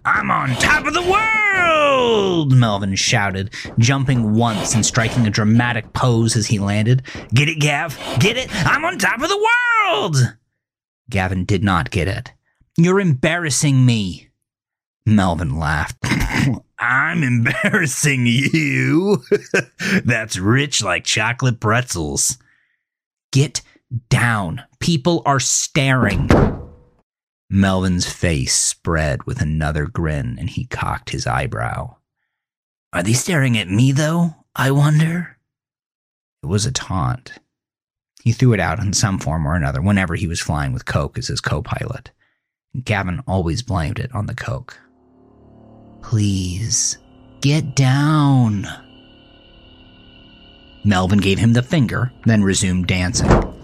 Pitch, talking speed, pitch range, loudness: 125 Hz, 125 wpm, 105-145 Hz, -17 LUFS